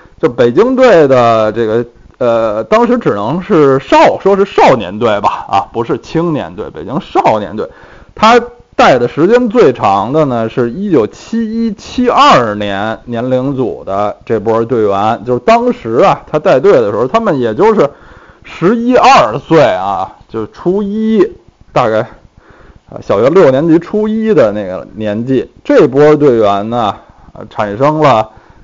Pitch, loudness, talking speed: 145 Hz, -10 LUFS, 215 characters per minute